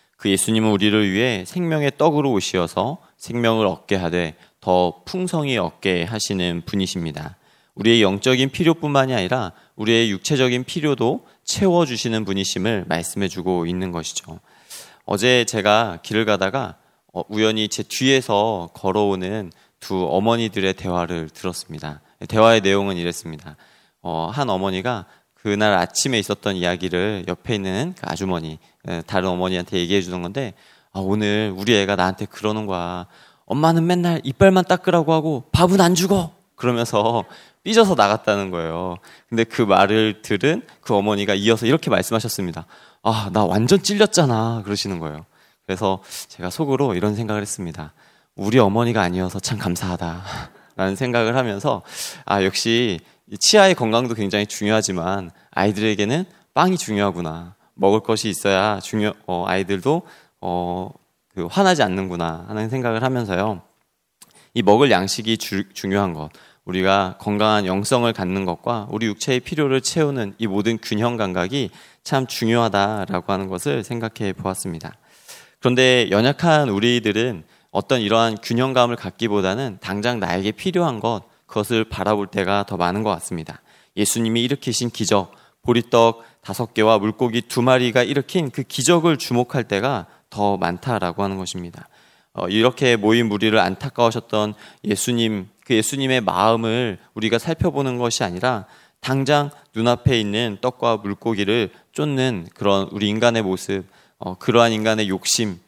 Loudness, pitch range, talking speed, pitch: -20 LUFS, 95-125 Hz, 335 characters per minute, 105 Hz